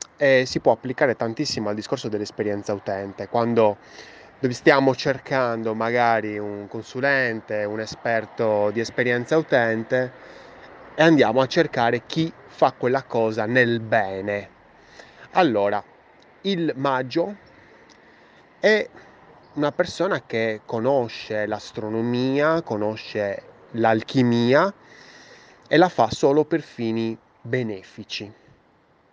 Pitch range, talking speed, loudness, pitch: 110-135 Hz, 100 wpm, -22 LUFS, 115 Hz